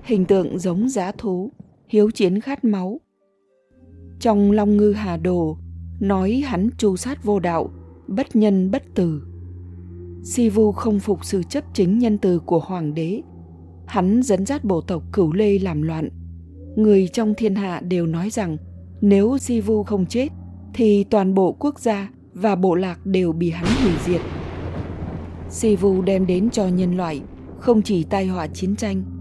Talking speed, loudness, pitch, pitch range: 170 wpm, -20 LUFS, 190 Hz, 155-210 Hz